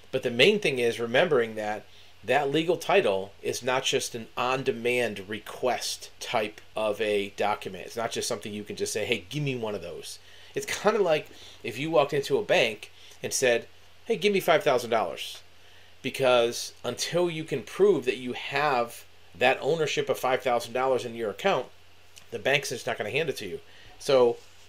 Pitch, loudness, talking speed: 130 Hz, -27 LUFS, 185 wpm